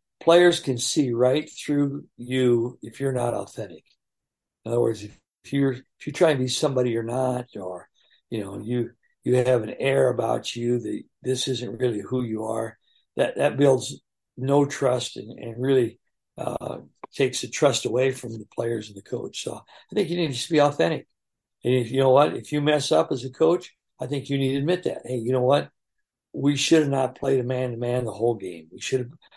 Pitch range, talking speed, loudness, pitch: 120-140 Hz, 215 wpm, -24 LUFS, 130 Hz